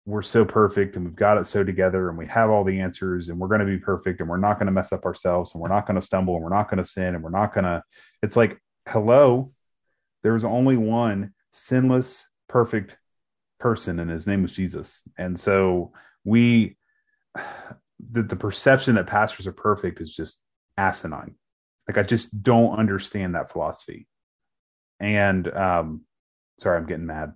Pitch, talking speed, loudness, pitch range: 100 Hz, 190 wpm, -23 LUFS, 90-110 Hz